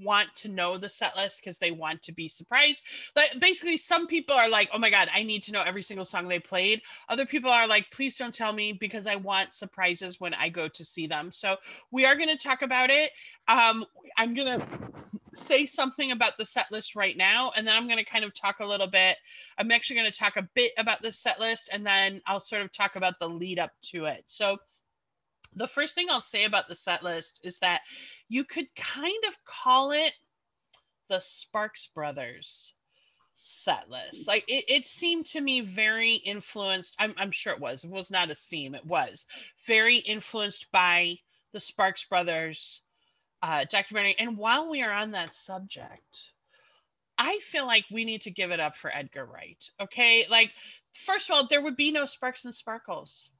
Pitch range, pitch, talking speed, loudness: 190-255 Hz, 215 Hz, 205 wpm, -26 LUFS